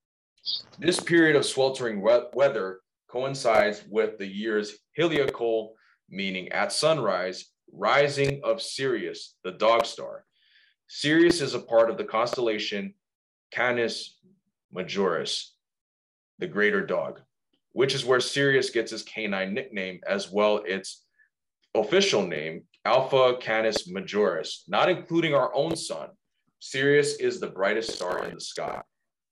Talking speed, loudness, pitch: 125 wpm, -26 LUFS, 125 Hz